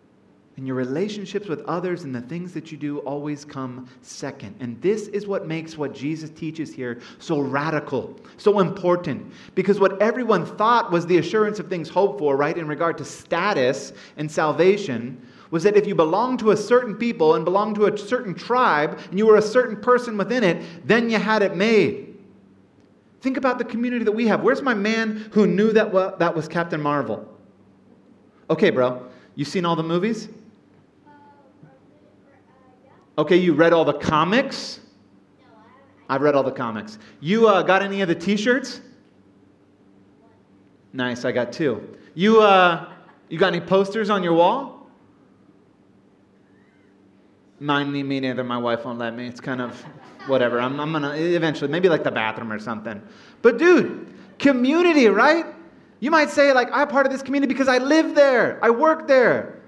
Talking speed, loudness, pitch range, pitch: 170 wpm, -20 LUFS, 135-215 Hz, 175 Hz